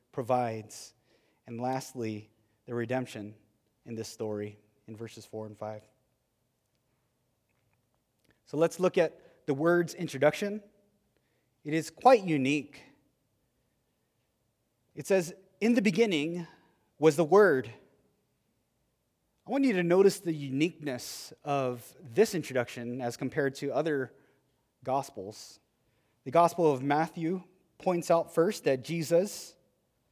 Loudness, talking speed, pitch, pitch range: -29 LUFS, 110 wpm, 135 Hz, 115-170 Hz